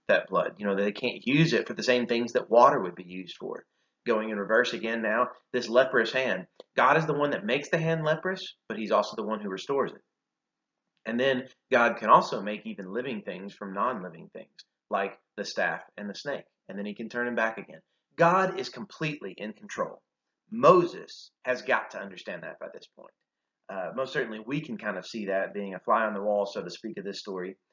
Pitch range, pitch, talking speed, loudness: 100-155 Hz, 120 Hz, 225 wpm, -28 LUFS